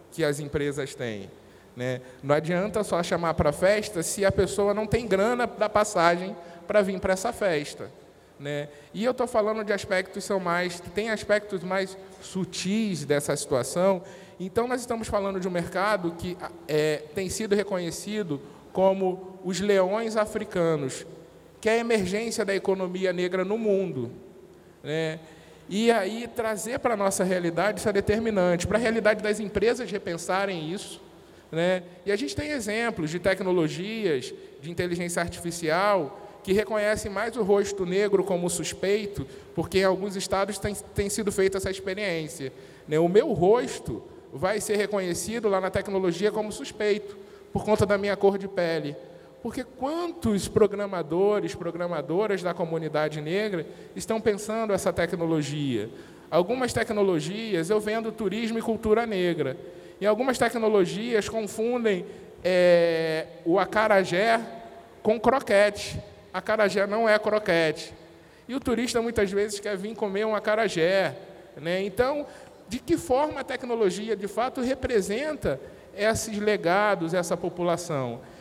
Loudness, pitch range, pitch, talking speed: -26 LUFS, 175-215 Hz, 195 Hz, 145 wpm